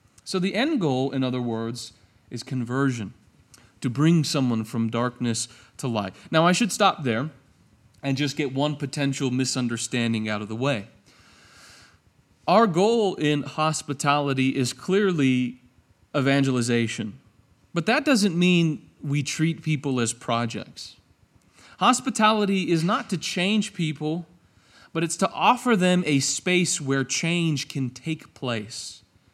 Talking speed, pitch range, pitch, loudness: 135 wpm, 115-165 Hz, 135 Hz, -24 LUFS